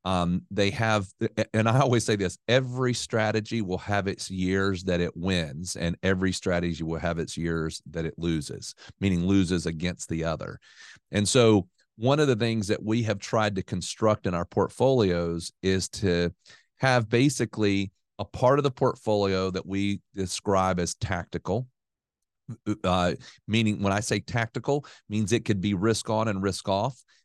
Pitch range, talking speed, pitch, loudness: 90-115 Hz, 165 wpm, 100 Hz, -26 LUFS